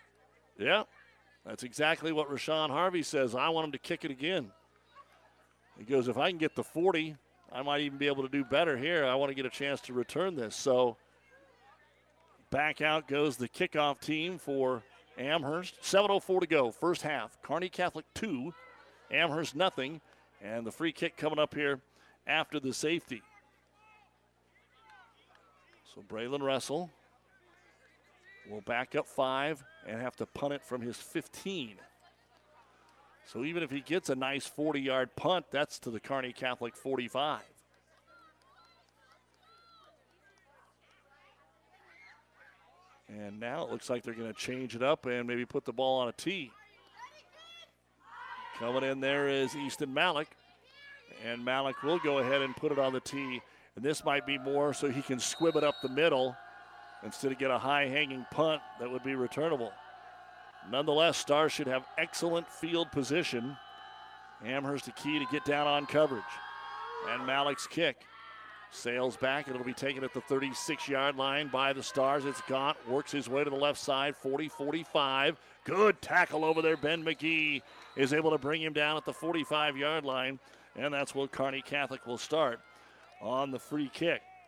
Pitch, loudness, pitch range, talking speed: 140 Hz, -33 LUFS, 130-155 Hz, 160 wpm